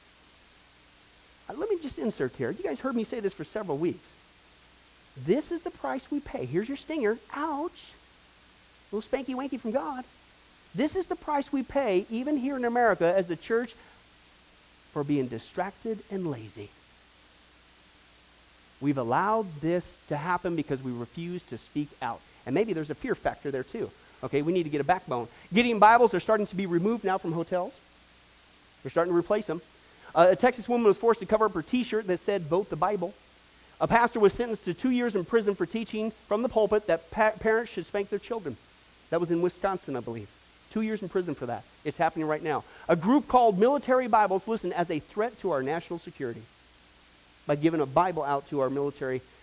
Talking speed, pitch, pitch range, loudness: 200 wpm, 180 Hz, 135-225 Hz, -28 LUFS